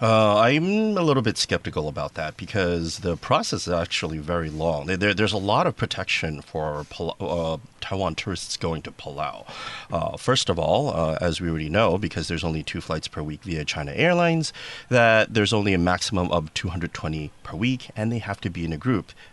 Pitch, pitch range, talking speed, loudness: 95 Hz, 80-110 Hz, 200 wpm, -24 LUFS